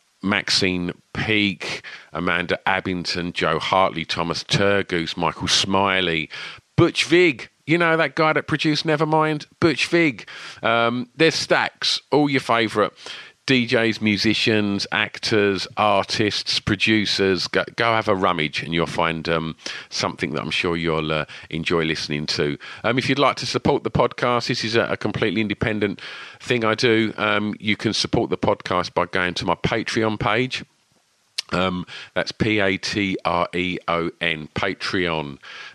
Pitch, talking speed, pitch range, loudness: 105 Hz, 150 wpm, 90-120 Hz, -21 LUFS